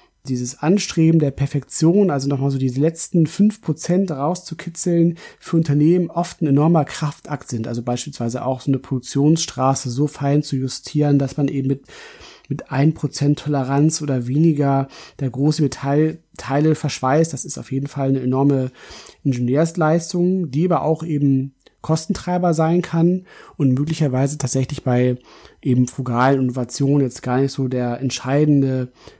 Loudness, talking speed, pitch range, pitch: -19 LUFS, 145 wpm, 135-160 Hz, 145 Hz